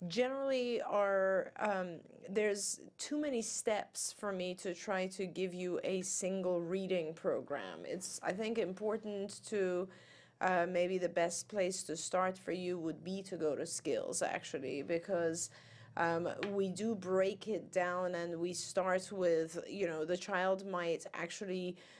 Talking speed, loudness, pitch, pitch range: 155 wpm, -38 LUFS, 185 Hz, 175-200 Hz